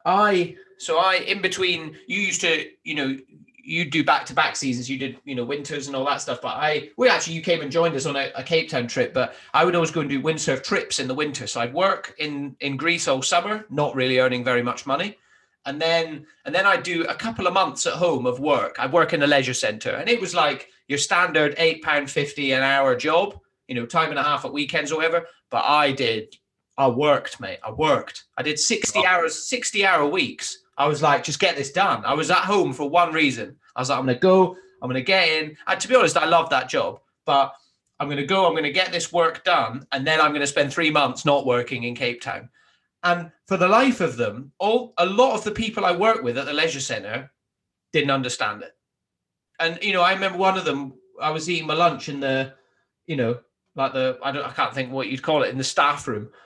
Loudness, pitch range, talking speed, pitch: -22 LUFS, 135-175 Hz, 250 wpm, 155 Hz